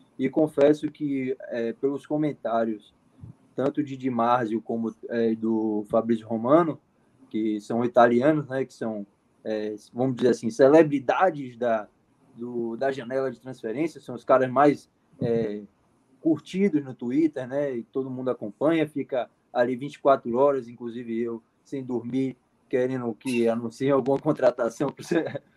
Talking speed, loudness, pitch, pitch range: 140 wpm, -25 LUFS, 130 Hz, 115-140 Hz